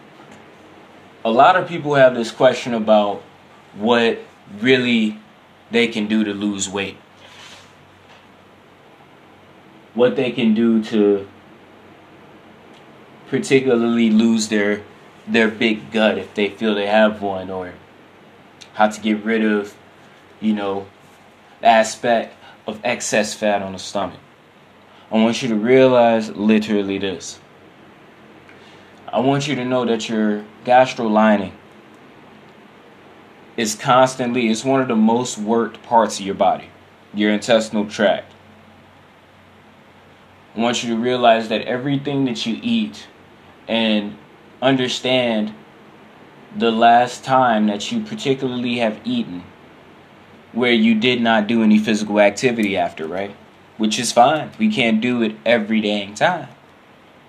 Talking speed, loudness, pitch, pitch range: 125 wpm, -18 LUFS, 110 Hz, 105-125 Hz